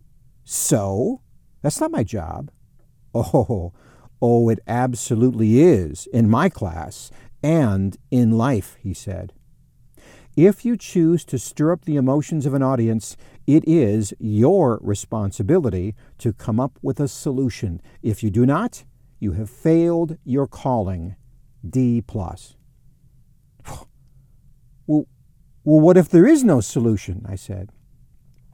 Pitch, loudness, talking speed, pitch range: 125 Hz, -19 LUFS, 130 wpm, 110-140 Hz